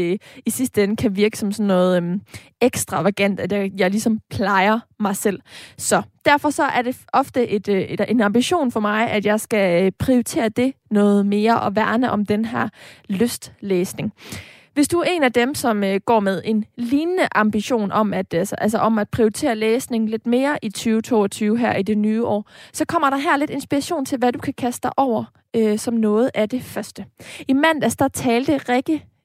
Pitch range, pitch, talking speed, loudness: 205-255 Hz, 225 Hz, 195 wpm, -20 LUFS